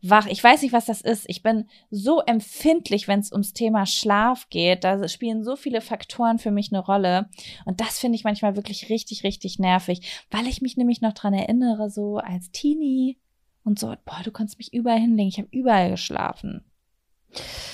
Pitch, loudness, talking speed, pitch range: 215 Hz, -23 LUFS, 190 wpm, 200-235 Hz